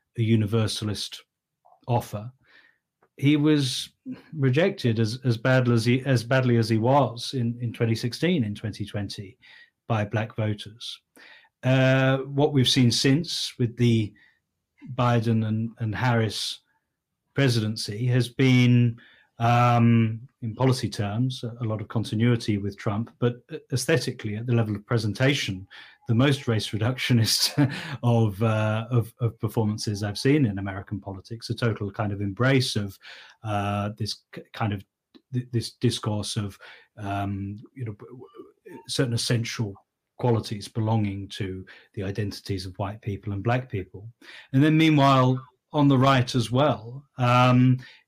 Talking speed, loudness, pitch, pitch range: 135 wpm, -24 LUFS, 120 Hz, 110-130 Hz